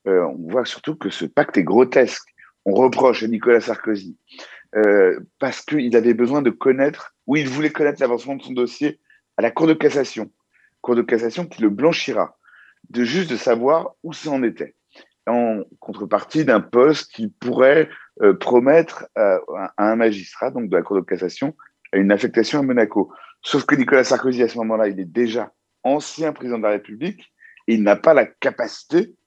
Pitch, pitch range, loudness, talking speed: 120 Hz, 110-140 Hz, -19 LUFS, 185 wpm